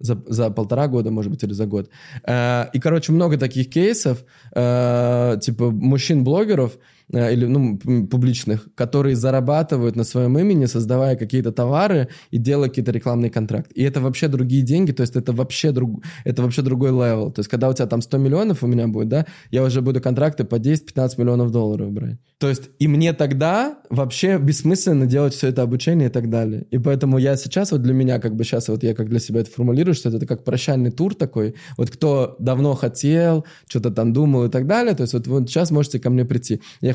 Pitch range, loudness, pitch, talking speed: 120-145 Hz, -19 LUFS, 130 Hz, 210 wpm